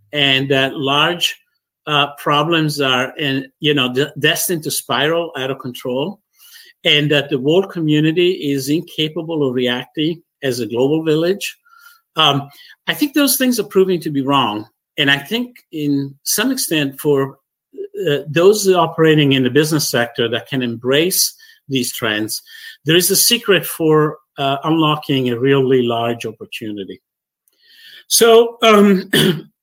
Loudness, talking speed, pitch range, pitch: -16 LUFS, 145 wpm, 135-190 Hz, 150 Hz